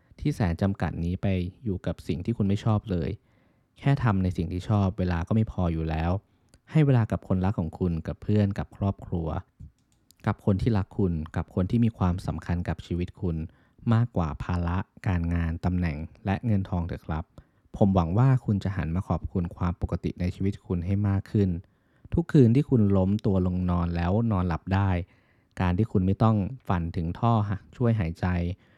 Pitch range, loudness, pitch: 90-105 Hz, -27 LUFS, 95 Hz